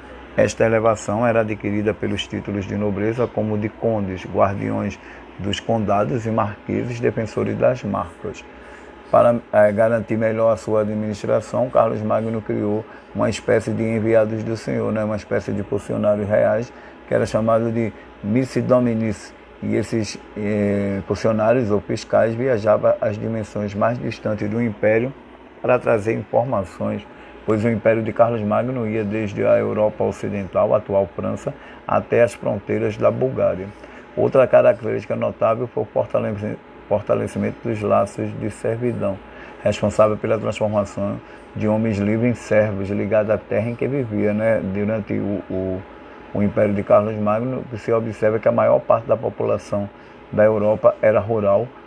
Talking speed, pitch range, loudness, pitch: 145 wpm, 105-115 Hz, -20 LUFS, 110 Hz